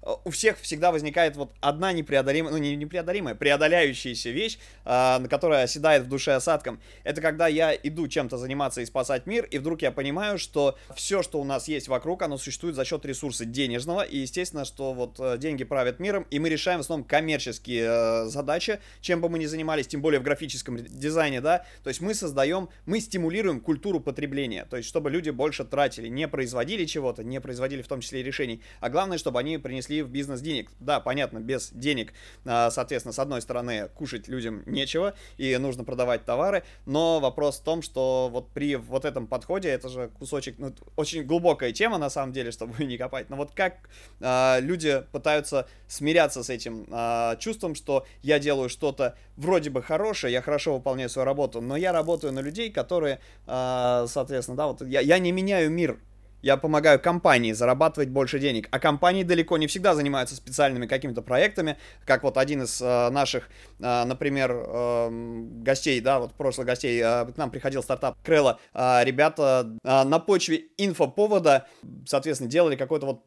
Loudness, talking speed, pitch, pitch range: -26 LUFS, 180 wpm, 140 Hz, 125-160 Hz